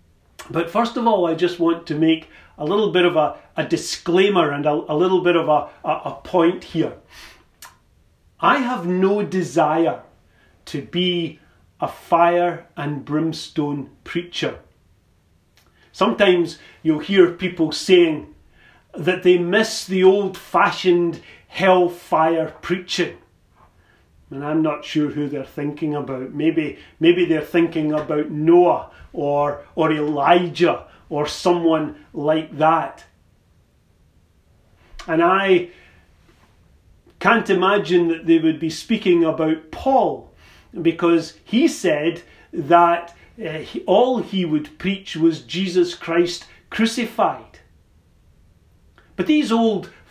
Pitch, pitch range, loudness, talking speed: 165 Hz, 150-180 Hz, -19 LUFS, 120 wpm